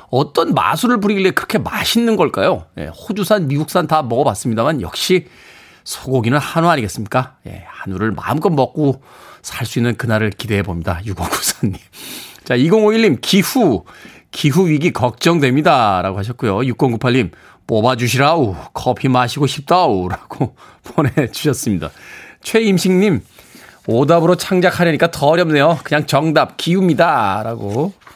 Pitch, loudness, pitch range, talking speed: 145 Hz, -15 LUFS, 120-170 Hz, 305 characters per minute